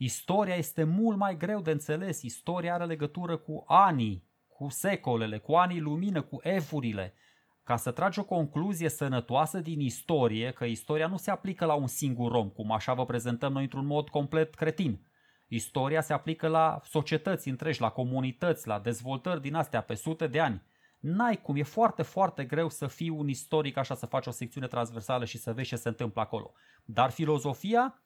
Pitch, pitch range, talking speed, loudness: 150 Hz, 125-165 Hz, 185 wpm, -31 LUFS